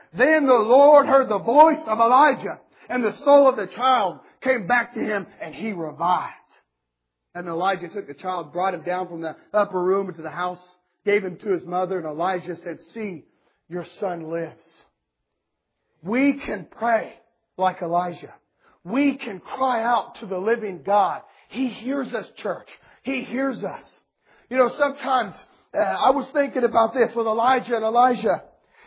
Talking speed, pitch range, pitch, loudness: 170 wpm, 180-255 Hz, 215 Hz, -22 LUFS